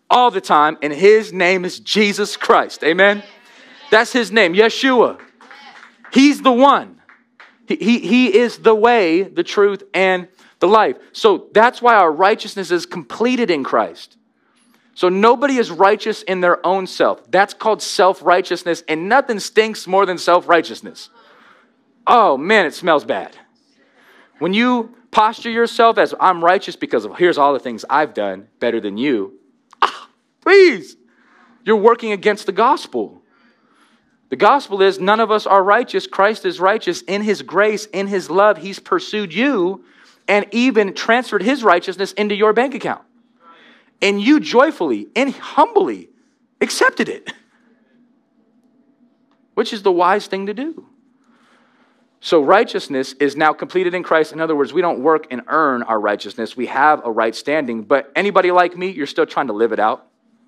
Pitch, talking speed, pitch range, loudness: 210 Hz, 160 wpm, 180-245 Hz, -16 LUFS